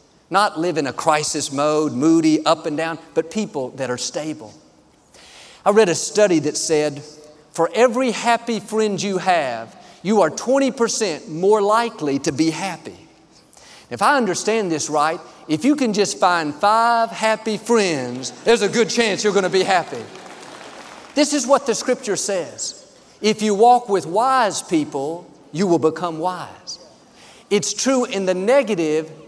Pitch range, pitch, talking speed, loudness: 160-230 Hz, 200 Hz, 160 wpm, -19 LUFS